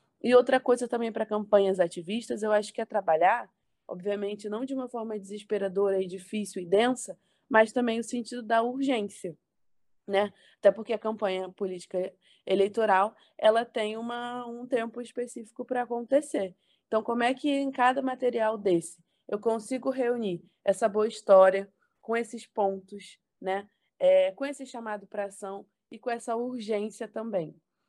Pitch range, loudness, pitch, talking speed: 195-240 Hz, -28 LUFS, 220 Hz, 155 wpm